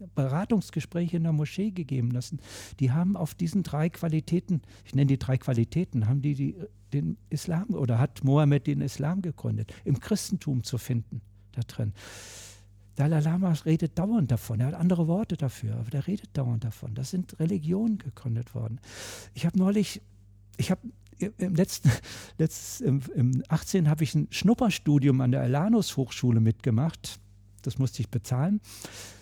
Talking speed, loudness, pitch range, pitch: 160 wpm, -28 LUFS, 115-170 Hz, 140 Hz